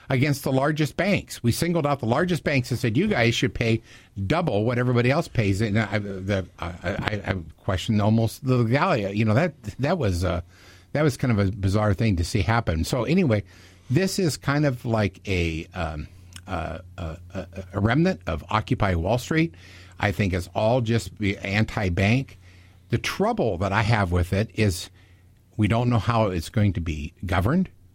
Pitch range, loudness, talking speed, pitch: 95-120 Hz, -24 LUFS, 185 wpm, 105 Hz